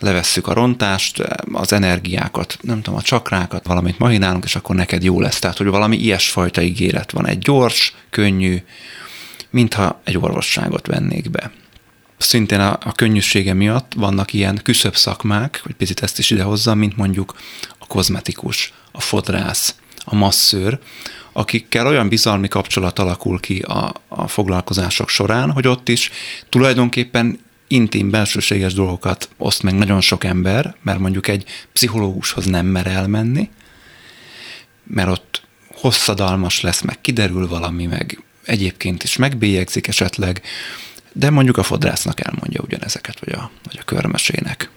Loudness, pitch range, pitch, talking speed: -17 LUFS, 95-115 Hz, 100 Hz, 140 wpm